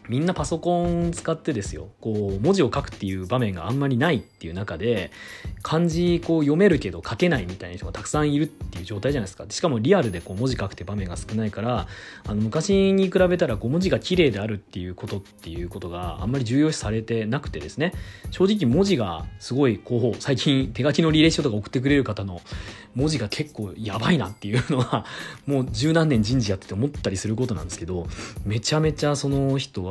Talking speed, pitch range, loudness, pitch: 460 characters per minute, 100-150 Hz, -24 LUFS, 120 Hz